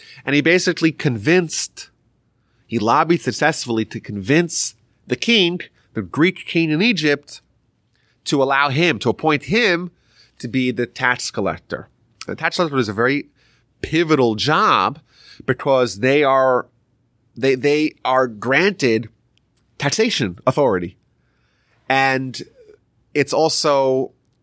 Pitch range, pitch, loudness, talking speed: 120-155 Hz, 130 Hz, -18 LUFS, 115 wpm